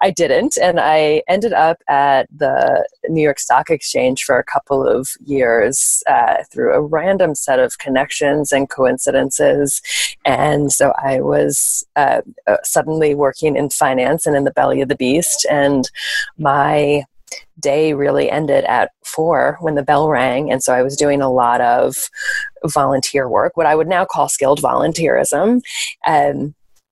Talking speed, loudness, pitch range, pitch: 160 wpm, -15 LUFS, 135-165 Hz, 145 Hz